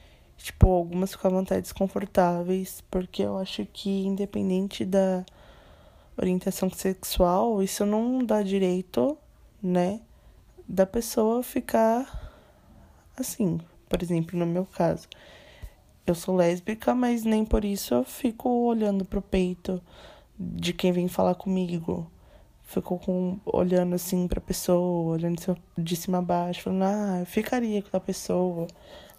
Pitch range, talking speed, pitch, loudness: 180-205 Hz, 125 wpm, 185 Hz, -27 LUFS